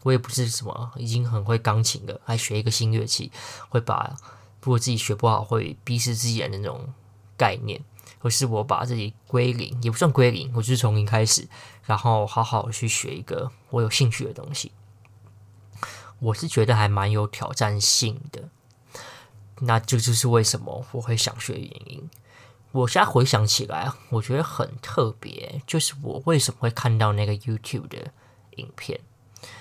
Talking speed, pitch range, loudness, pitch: 270 characters per minute, 110-130 Hz, -24 LUFS, 120 Hz